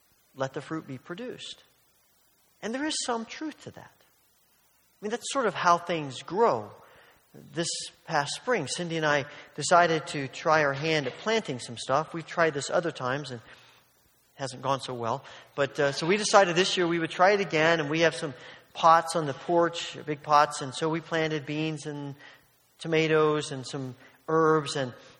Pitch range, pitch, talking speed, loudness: 145-170 Hz, 155 Hz, 190 wpm, -27 LUFS